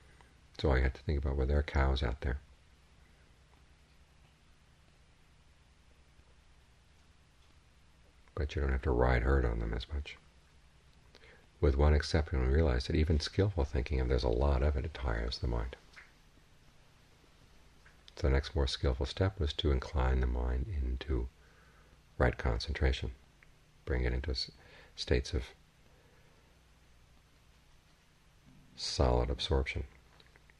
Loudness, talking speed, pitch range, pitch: -34 LUFS, 120 wpm, 65-80 Hz, 75 Hz